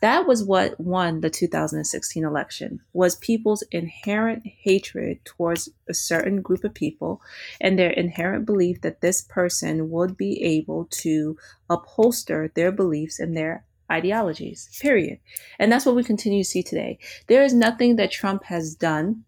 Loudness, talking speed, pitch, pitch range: -23 LUFS, 155 wpm, 180 Hz, 165-210 Hz